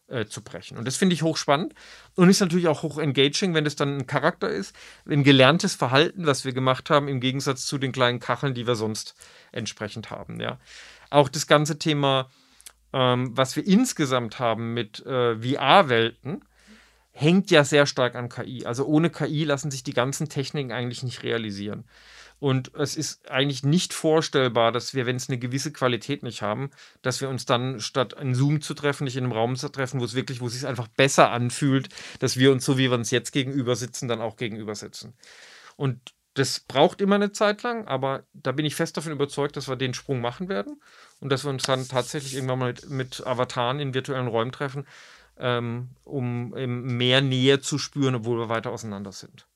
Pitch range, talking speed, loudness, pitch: 125-145 Hz, 200 wpm, -24 LUFS, 135 Hz